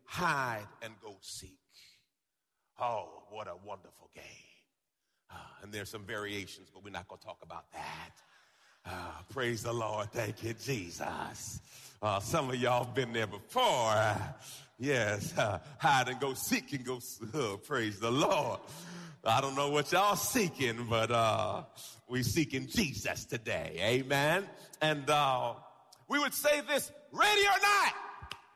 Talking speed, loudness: 150 wpm, -32 LUFS